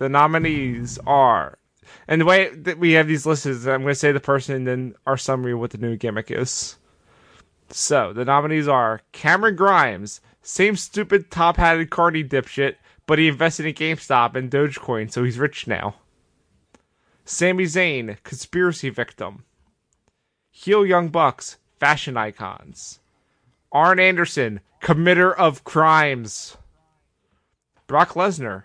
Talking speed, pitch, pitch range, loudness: 140 wpm, 145 Hz, 125-170 Hz, -19 LUFS